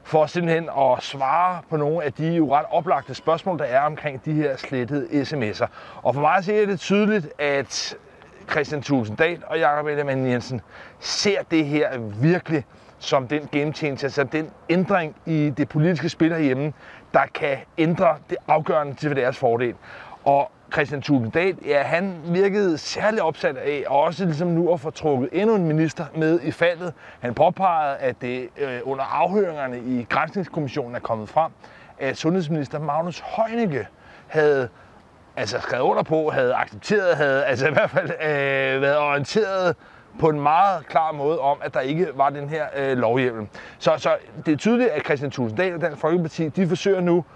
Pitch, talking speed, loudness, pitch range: 155 Hz, 175 wpm, -22 LUFS, 140-170 Hz